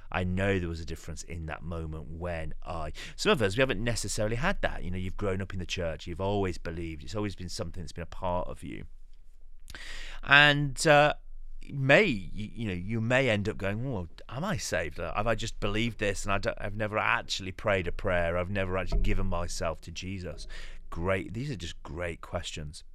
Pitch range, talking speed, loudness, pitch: 85-105 Hz, 215 wpm, -30 LUFS, 95 Hz